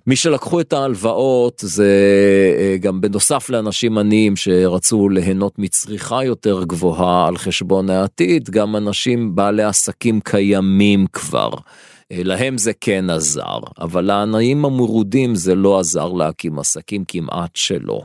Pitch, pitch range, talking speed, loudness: 100 Hz, 95-115 Hz, 125 wpm, -16 LUFS